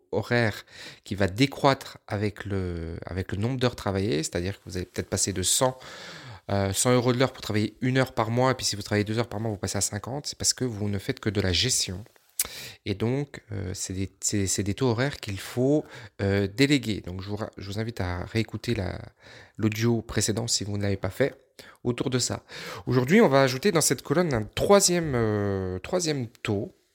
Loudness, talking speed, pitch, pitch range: -26 LUFS, 215 wpm, 110 Hz, 100-130 Hz